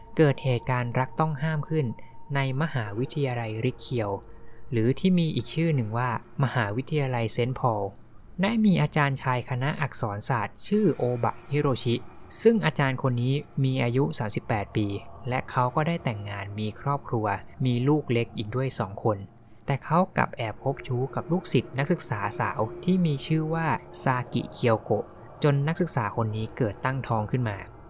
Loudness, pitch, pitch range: -27 LUFS, 130 Hz, 115-145 Hz